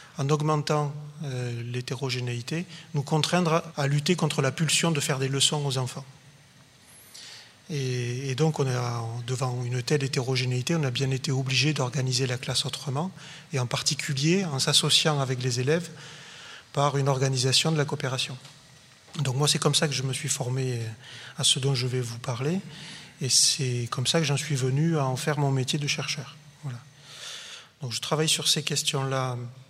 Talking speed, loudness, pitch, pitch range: 180 wpm, -26 LUFS, 140 Hz, 130-155 Hz